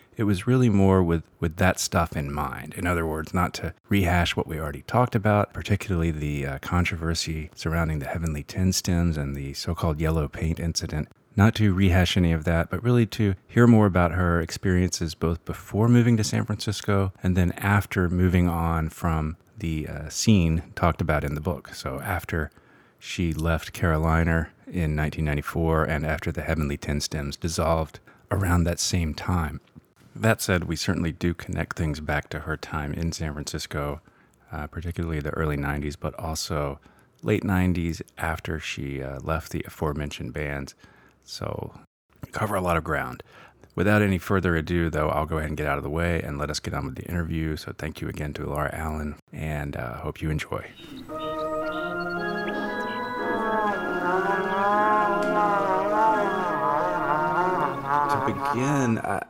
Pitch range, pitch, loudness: 80-100 Hz, 85 Hz, -25 LUFS